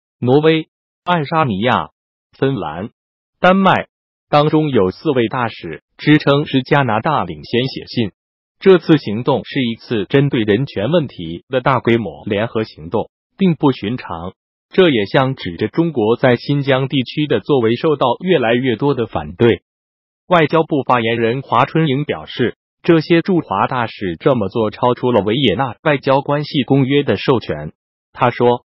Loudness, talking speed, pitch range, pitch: -16 LUFS, 235 characters per minute, 115-150 Hz, 130 Hz